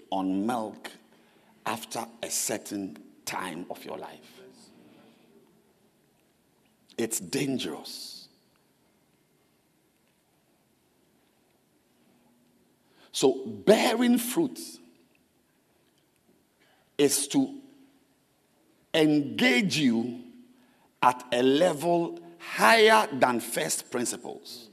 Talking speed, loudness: 60 wpm, -26 LUFS